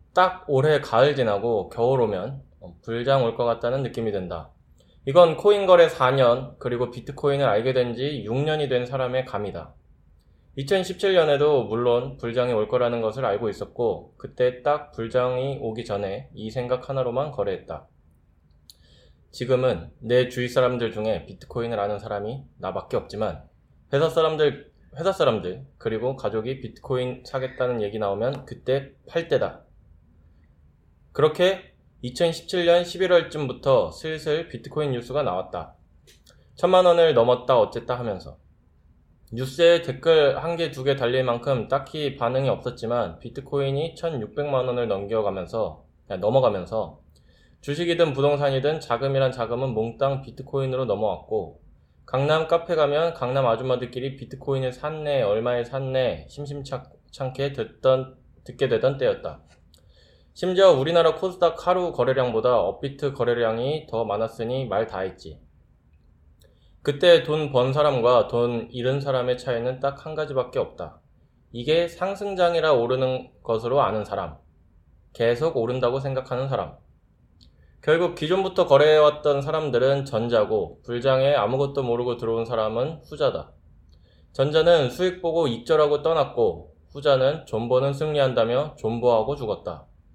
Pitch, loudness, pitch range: 130 Hz, -23 LUFS, 115-150 Hz